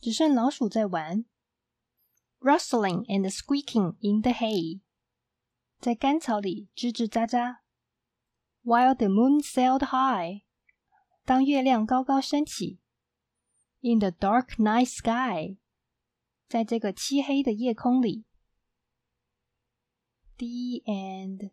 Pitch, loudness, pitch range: 235 Hz, -26 LUFS, 195-260 Hz